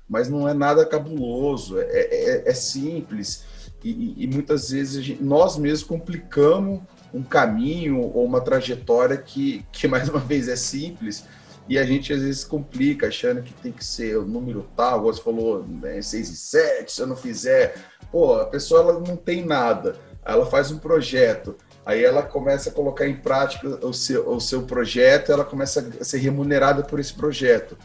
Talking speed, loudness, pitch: 185 wpm, -22 LUFS, 150 Hz